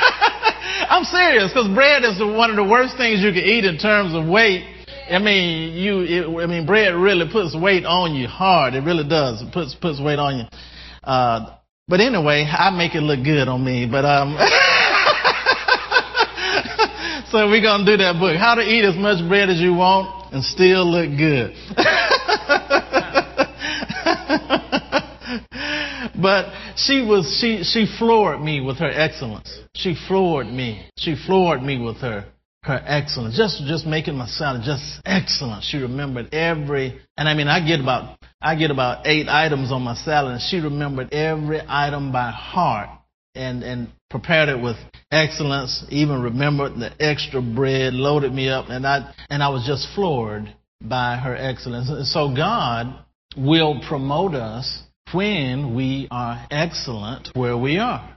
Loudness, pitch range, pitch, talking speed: -18 LUFS, 130-195 Hz, 155 Hz, 165 wpm